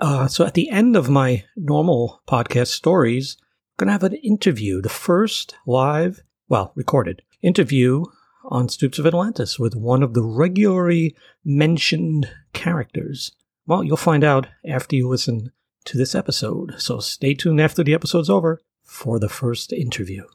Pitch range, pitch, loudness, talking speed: 125-170 Hz, 150 Hz, -19 LUFS, 160 wpm